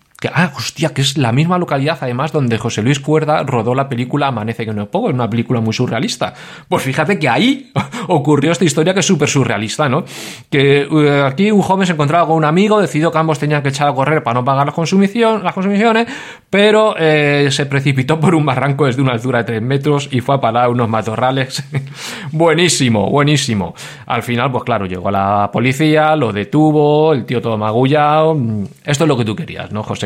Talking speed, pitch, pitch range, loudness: 210 wpm, 145 Hz, 125-160 Hz, -14 LUFS